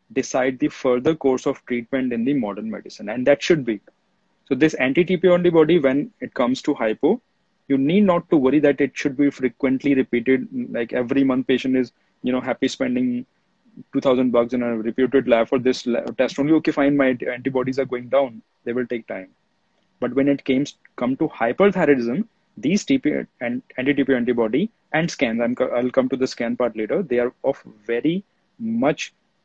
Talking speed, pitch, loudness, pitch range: 190 wpm, 135 Hz, -21 LUFS, 125-175 Hz